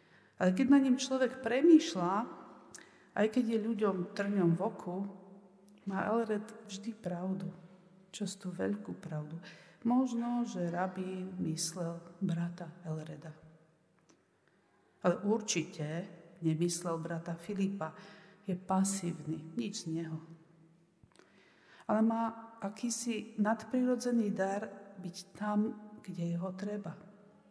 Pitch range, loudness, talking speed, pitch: 170-215 Hz, -34 LUFS, 100 wpm, 190 Hz